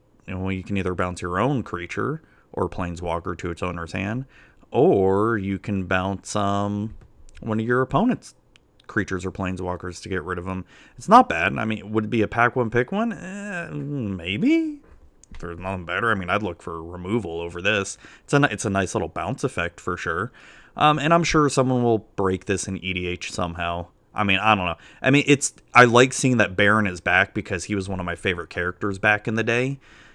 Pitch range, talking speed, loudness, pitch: 90-120 Hz, 210 wpm, -23 LUFS, 100 Hz